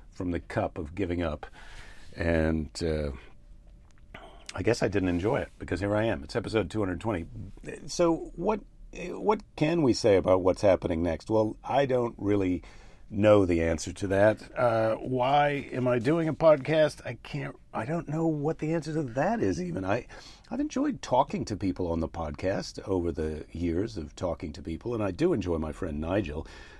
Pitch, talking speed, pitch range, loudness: 105 Hz, 190 wpm, 85-140 Hz, -28 LUFS